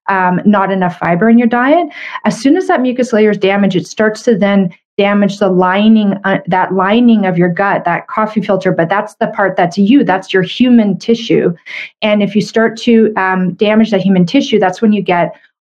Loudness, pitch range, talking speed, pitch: -11 LUFS, 190-225 Hz, 210 wpm, 200 Hz